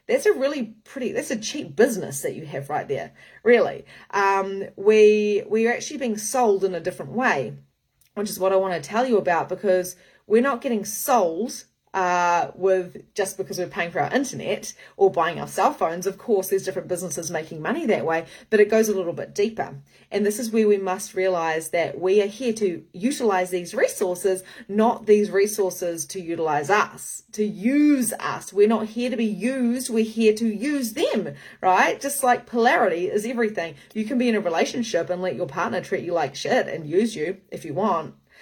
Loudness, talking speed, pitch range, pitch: -23 LUFS, 200 wpm, 180-235 Hz, 205 Hz